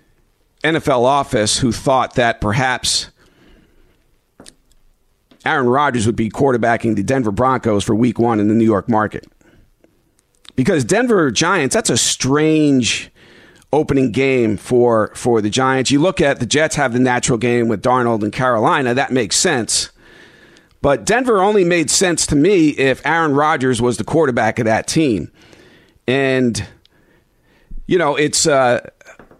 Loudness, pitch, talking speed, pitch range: -15 LUFS, 125 Hz, 145 wpm, 115-135 Hz